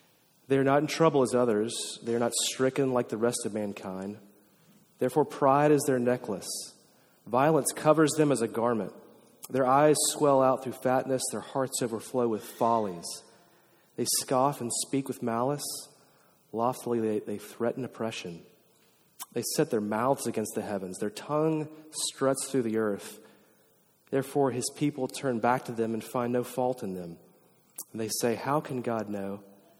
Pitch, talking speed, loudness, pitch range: 125 Hz, 165 wpm, -29 LUFS, 110-140 Hz